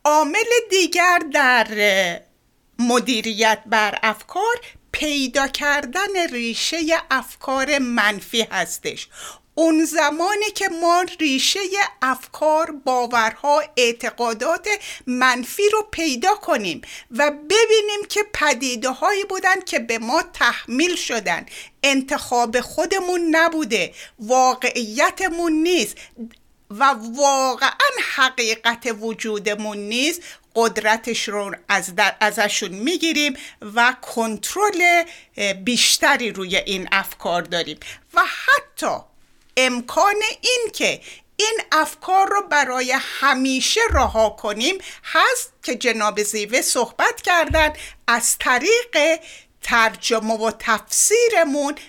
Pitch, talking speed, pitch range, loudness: 275 Hz, 95 wpm, 230-340 Hz, -19 LUFS